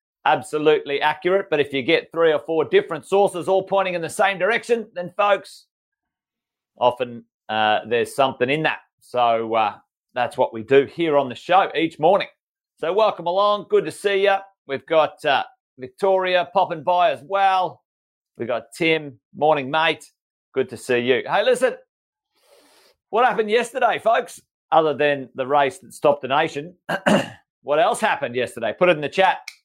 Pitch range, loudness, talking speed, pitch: 145-200 Hz, -20 LUFS, 170 wpm, 175 Hz